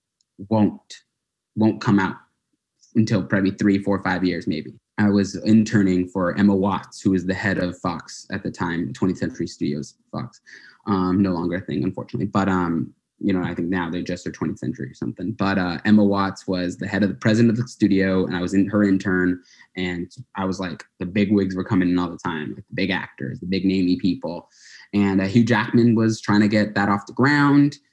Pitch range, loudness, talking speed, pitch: 90-105 Hz, -21 LUFS, 220 wpm, 95 Hz